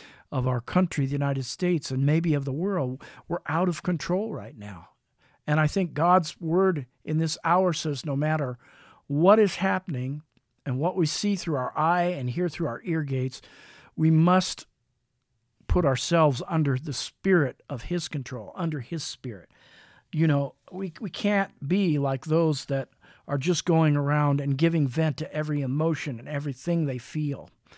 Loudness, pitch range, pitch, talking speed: -26 LUFS, 135-170 Hz, 150 Hz, 175 wpm